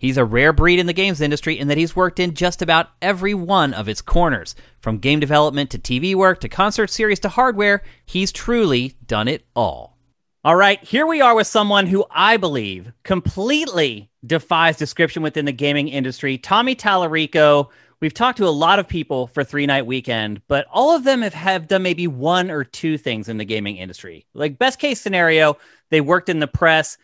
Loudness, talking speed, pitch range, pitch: -18 LUFS, 200 wpm, 140-195 Hz, 165 Hz